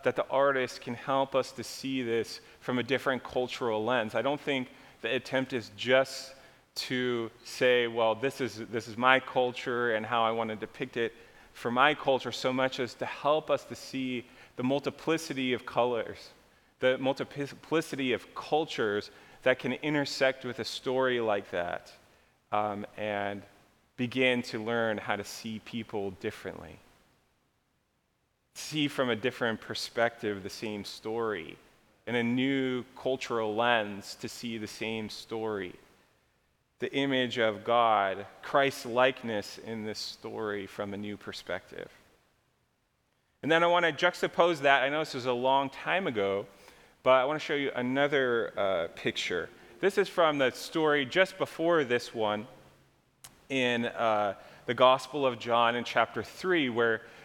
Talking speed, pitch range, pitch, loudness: 155 wpm, 110-135 Hz, 125 Hz, -30 LUFS